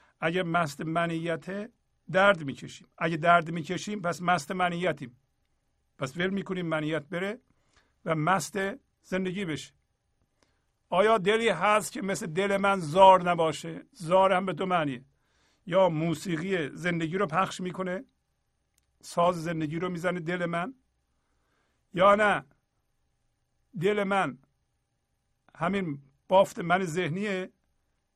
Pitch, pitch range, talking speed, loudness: 175 Hz, 160-190 Hz, 115 wpm, -27 LUFS